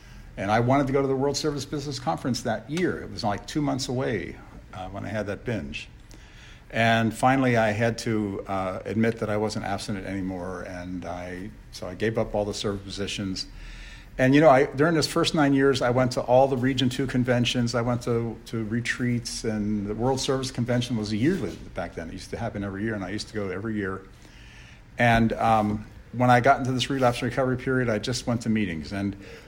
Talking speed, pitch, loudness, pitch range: 220 wpm, 115 Hz, -25 LUFS, 100-130 Hz